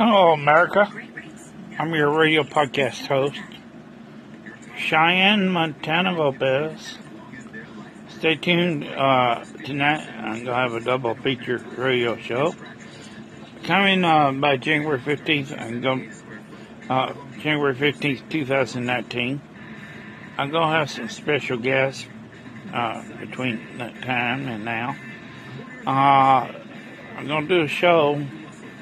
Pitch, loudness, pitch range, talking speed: 140 Hz, -21 LUFS, 125-155 Hz, 105 wpm